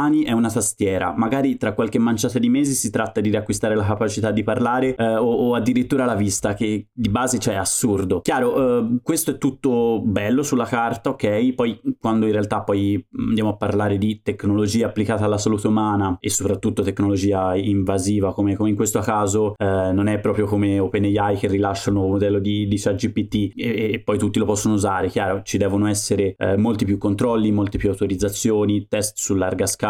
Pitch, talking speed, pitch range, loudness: 105 Hz, 195 wpm, 100-115 Hz, -20 LUFS